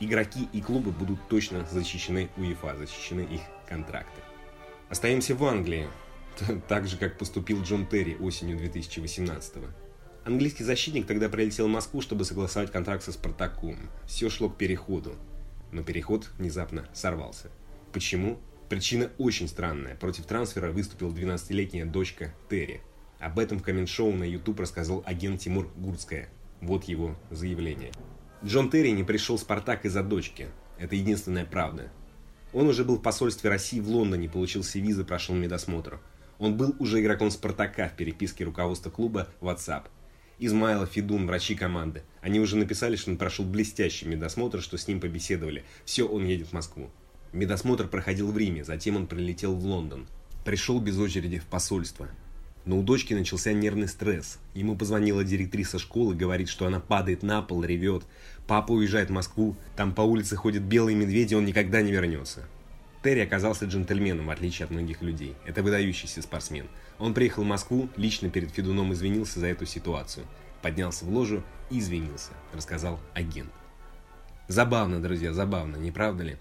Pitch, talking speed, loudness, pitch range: 95 Hz, 155 wpm, -29 LUFS, 85-105 Hz